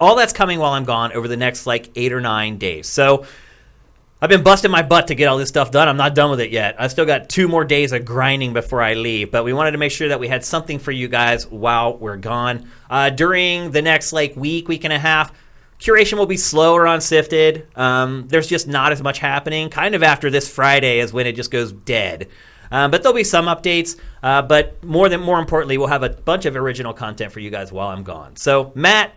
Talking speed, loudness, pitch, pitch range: 245 wpm, -16 LUFS, 140 Hz, 125-160 Hz